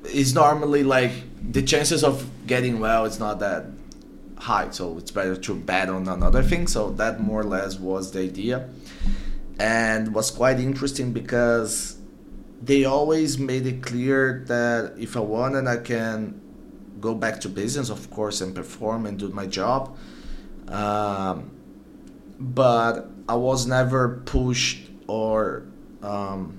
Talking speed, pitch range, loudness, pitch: 145 wpm, 105-130 Hz, -24 LUFS, 115 Hz